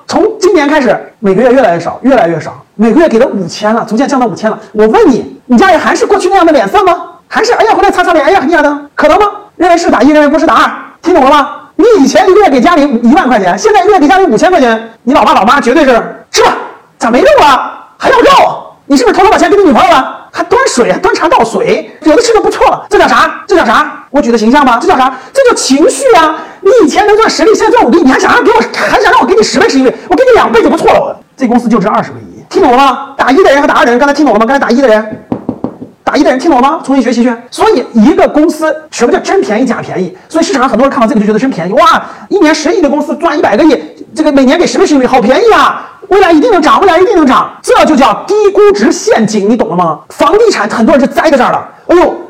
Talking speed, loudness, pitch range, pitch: 405 characters per minute, -7 LUFS, 255-380 Hz, 310 Hz